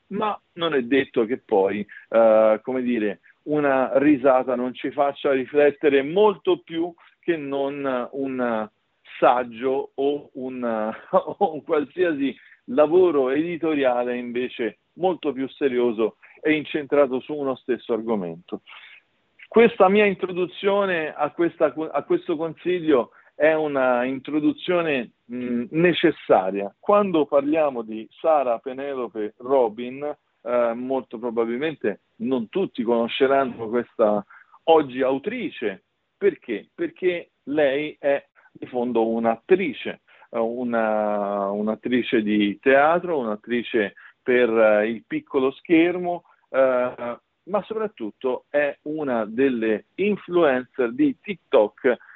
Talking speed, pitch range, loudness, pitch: 105 wpm, 120-165 Hz, -23 LUFS, 140 Hz